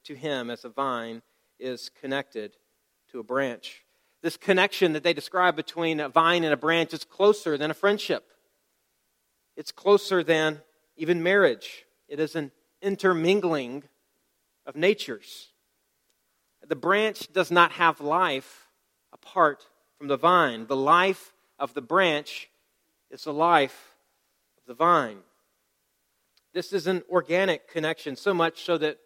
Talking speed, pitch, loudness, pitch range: 140 wpm, 165 Hz, -25 LUFS, 145-185 Hz